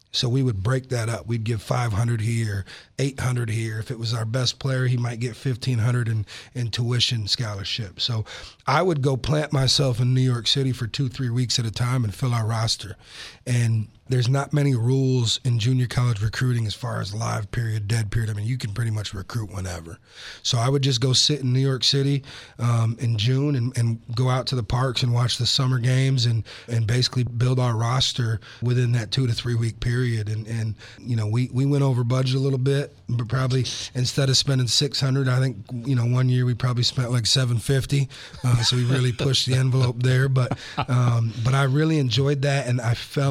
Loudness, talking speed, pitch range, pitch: -23 LUFS, 215 wpm, 115-130 Hz, 125 Hz